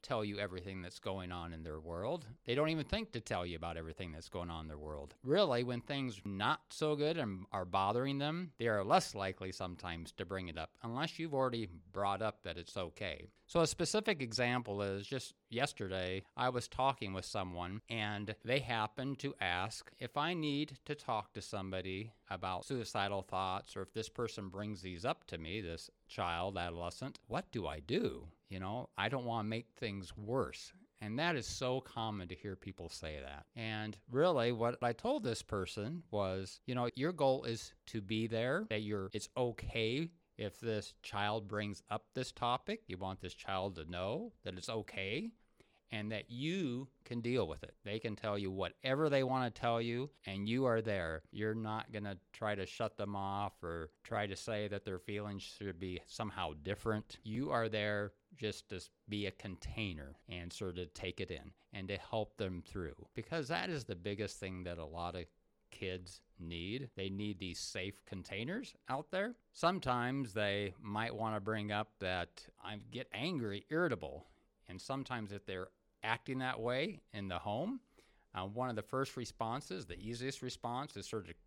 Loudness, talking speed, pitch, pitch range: -40 LUFS, 195 wpm, 105 Hz, 95-125 Hz